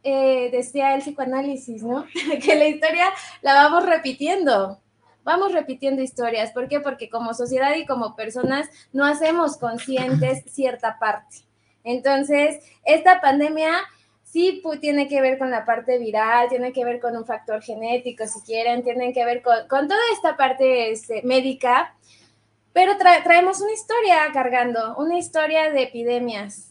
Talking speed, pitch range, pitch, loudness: 155 wpm, 240-310 Hz, 265 Hz, -20 LUFS